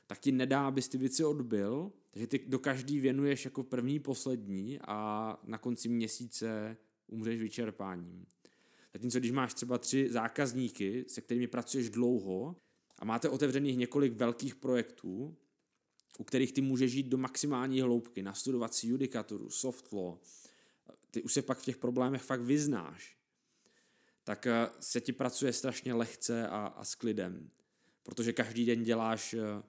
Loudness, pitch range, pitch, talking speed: -34 LUFS, 115-135 Hz, 125 Hz, 150 wpm